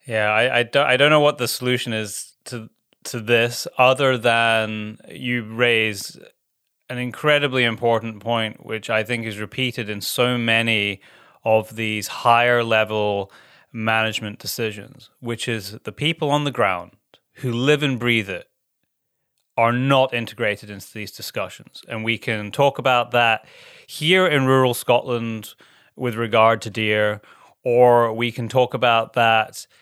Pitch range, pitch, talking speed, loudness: 110-125 Hz, 115 Hz, 150 wpm, -20 LUFS